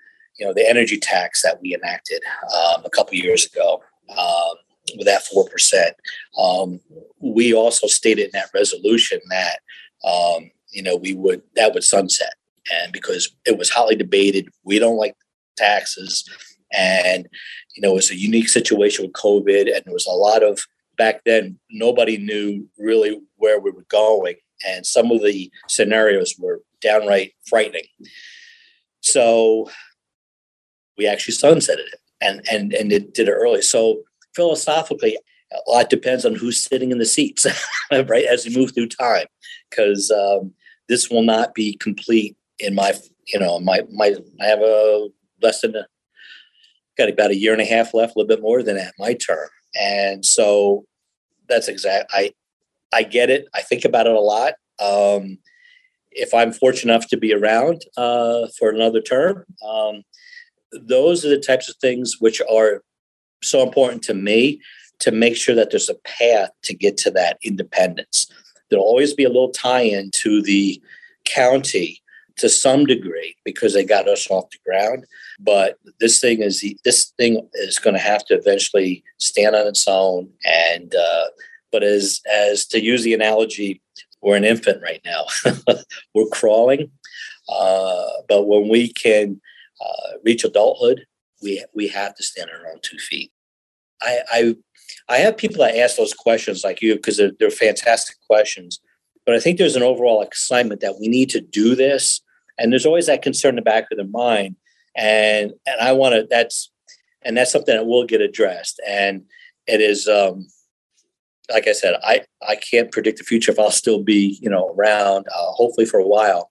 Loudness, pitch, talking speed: -17 LUFS, 120 Hz, 175 wpm